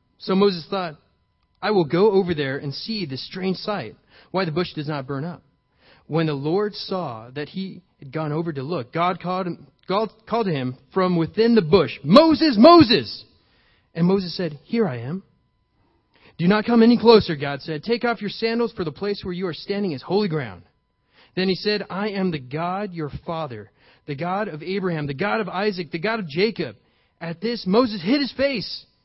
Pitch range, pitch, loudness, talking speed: 150-205 Hz, 180 Hz, -21 LUFS, 200 wpm